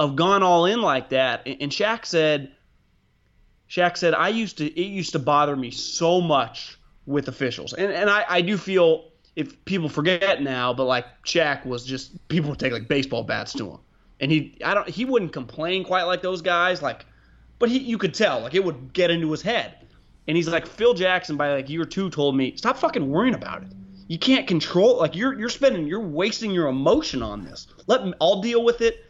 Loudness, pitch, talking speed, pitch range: -22 LUFS, 170 Hz, 215 wpm, 140-195 Hz